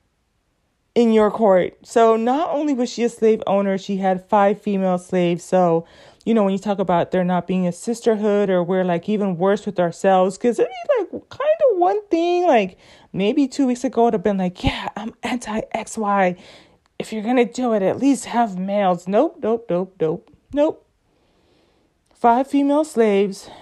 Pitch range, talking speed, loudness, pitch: 190-245 Hz, 190 wpm, -19 LUFS, 215 Hz